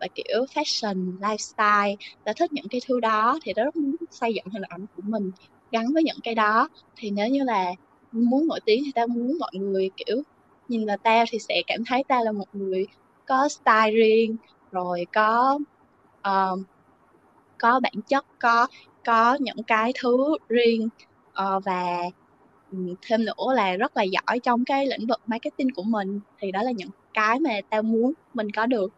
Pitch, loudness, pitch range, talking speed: 225 Hz, -24 LUFS, 205-255 Hz, 185 wpm